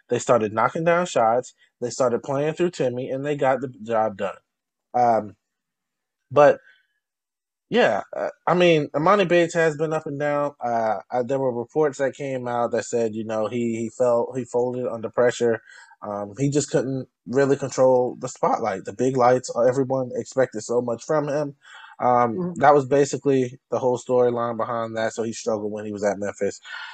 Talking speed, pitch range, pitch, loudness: 180 wpm, 120-145 Hz, 125 Hz, -22 LUFS